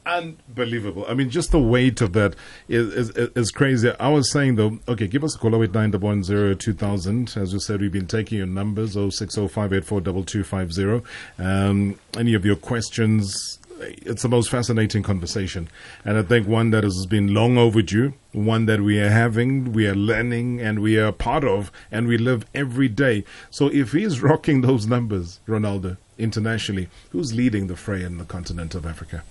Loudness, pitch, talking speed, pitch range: -22 LUFS, 110 Hz, 175 wpm, 100-120 Hz